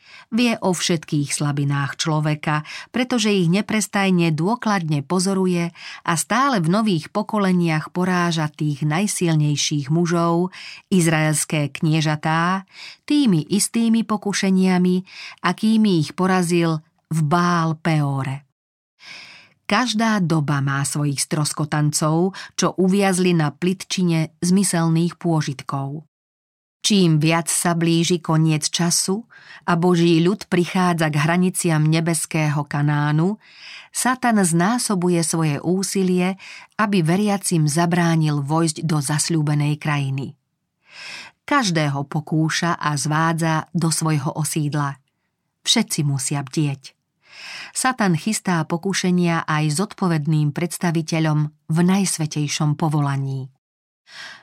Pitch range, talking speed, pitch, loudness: 155-185 Hz, 95 wpm, 170 Hz, -20 LUFS